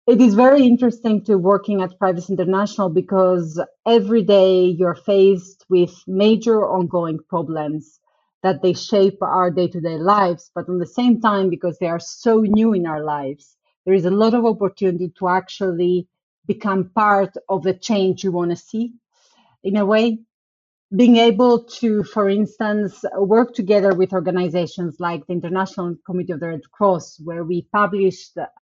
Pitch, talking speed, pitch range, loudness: 190 Hz, 165 wpm, 180-210 Hz, -18 LUFS